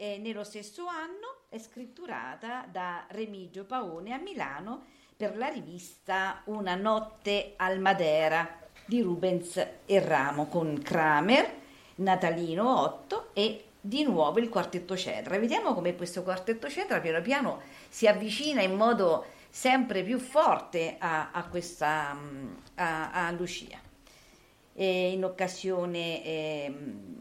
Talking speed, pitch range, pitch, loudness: 125 wpm, 170-225 Hz, 190 Hz, -30 LUFS